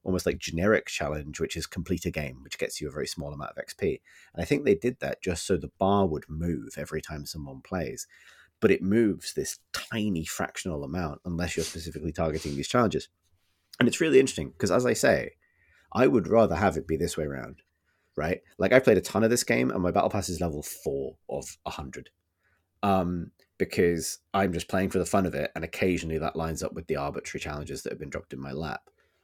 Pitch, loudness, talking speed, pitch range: 85 Hz, -28 LUFS, 225 wpm, 80-90 Hz